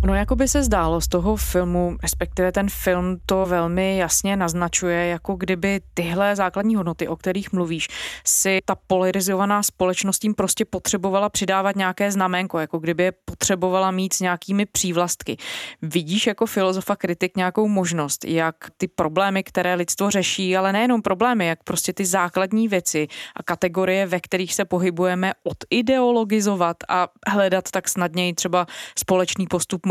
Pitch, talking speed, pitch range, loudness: 185 Hz, 150 wpm, 180-200 Hz, -21 LUFS